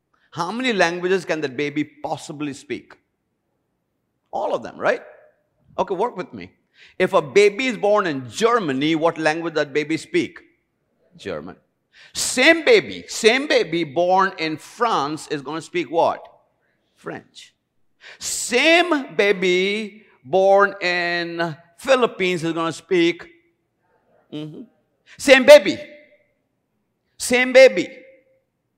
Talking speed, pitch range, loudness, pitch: 115 wpm, 165-265 Hz, -18 LUFS, 190 Hz